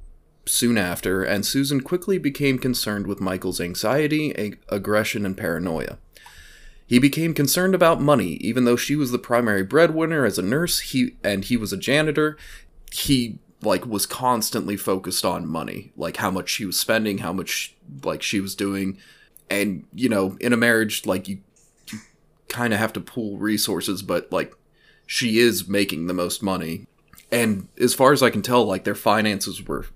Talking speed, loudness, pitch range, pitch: 175 wpm, -22 LUFS, 100-135 Hz, 110 Hz